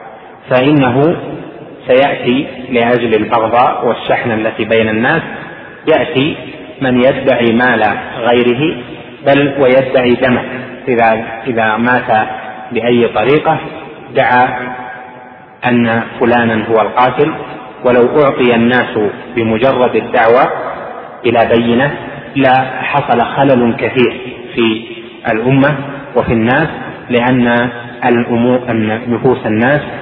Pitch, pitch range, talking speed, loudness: 125 Hz, 115-130 Hz, 85 wpm, -12 LUFS